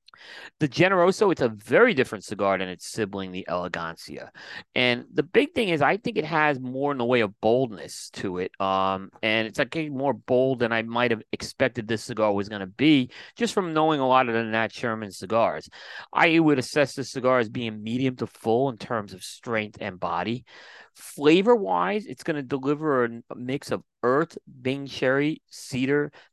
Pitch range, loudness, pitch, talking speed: 110-145 Hz, -25 LUFS, 125 Hz, 195 wpm